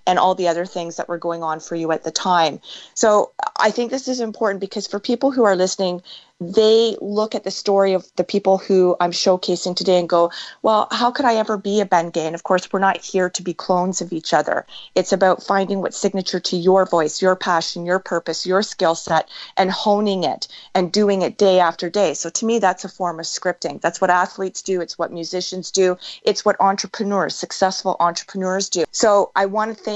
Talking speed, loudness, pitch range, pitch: 225 wpm, -19 LUFS, 175-200 Hz, 185 Hz